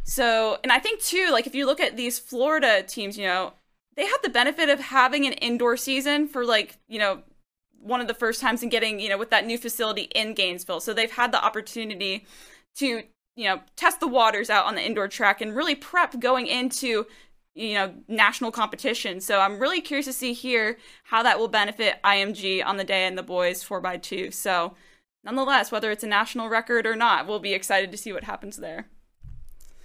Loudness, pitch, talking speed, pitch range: -24 LUFS, 225 Hz, 215 wpm, 200-255 Hz